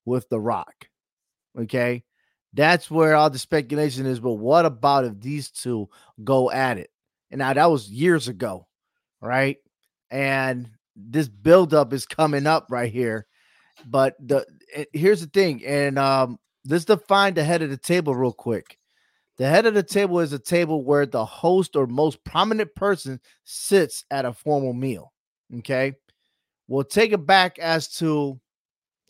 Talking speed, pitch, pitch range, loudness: 160 wpm, 140 Hz, 125-165 Hz, -22 LUFS